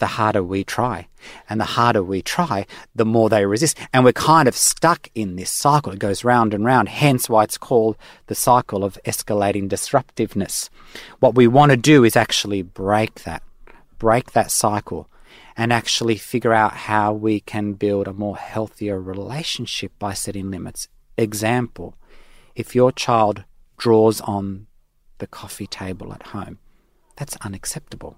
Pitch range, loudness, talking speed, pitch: 100-120 Hz, -19 LUFS, 160 wpm, 105 Hz